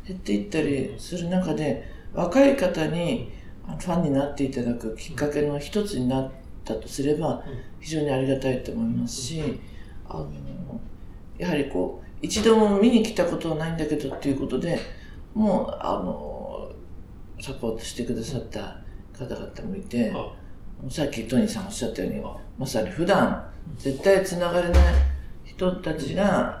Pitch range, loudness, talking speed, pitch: 110-170 Hz, -25 LUFS, 315 characters per minute, 135 Hz